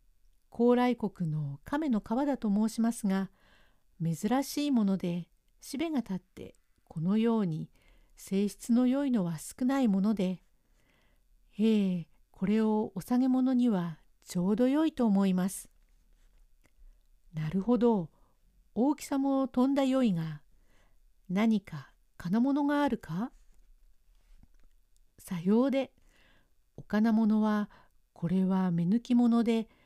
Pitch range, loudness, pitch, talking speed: 175-245 Hz, -30 LUFS, 210 Hz, 210 characters per minute